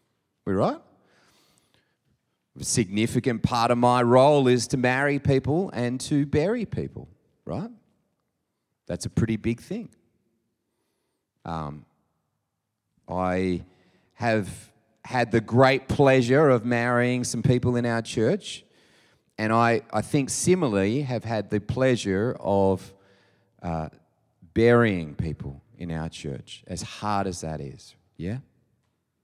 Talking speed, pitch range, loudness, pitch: 120 wpm, 95-125 Hz, -24 LUFS, 115 Hz